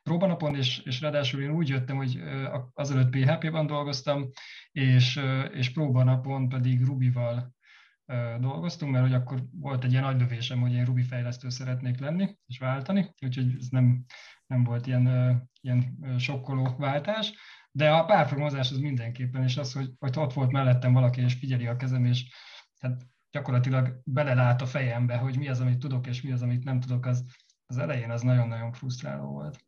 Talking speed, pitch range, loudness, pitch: 165 wpm, 125-140 Hz, -28 LUFS, 130 Hz